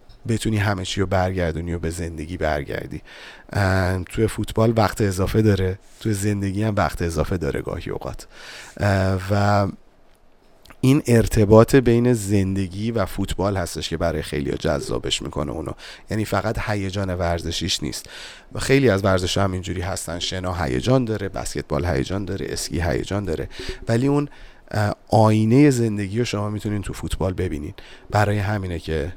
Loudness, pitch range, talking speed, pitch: -22 LUFS, 90-110 Hz, 145 wpm, 95 Hz